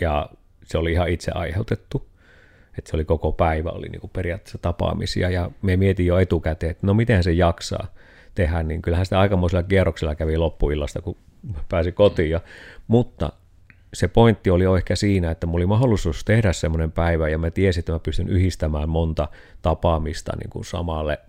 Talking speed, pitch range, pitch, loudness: 175 wpm, 80-95 Hz, 85 Hz, -22 LUFS